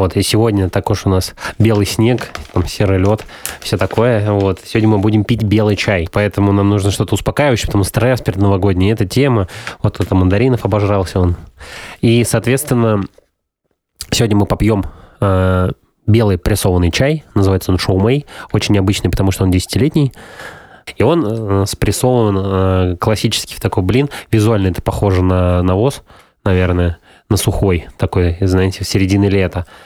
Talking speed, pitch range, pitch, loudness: 160 wpm, 95-110 Hz, 100 Hz, -14 LUFS